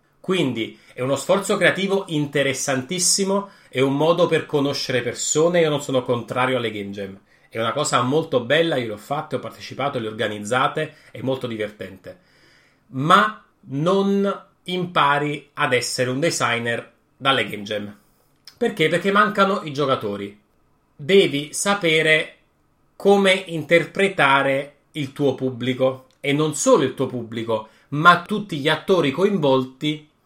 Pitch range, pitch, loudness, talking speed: 125-170 Hz, 145 Hz, -20 LUFS, 135 wpm